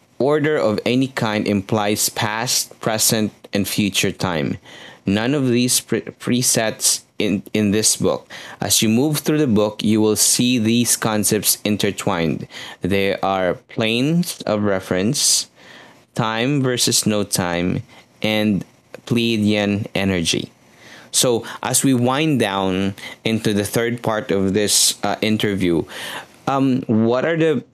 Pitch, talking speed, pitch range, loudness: 110 Hz, 130 wpm, 100-125 Hz, -18 LUFS